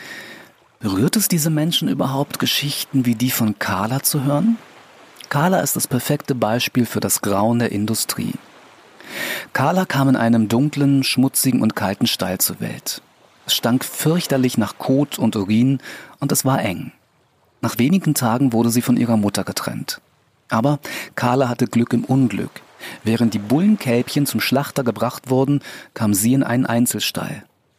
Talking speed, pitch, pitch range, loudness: 155 wpm, 125 Hz, 115-140 Hz, -19 LUFS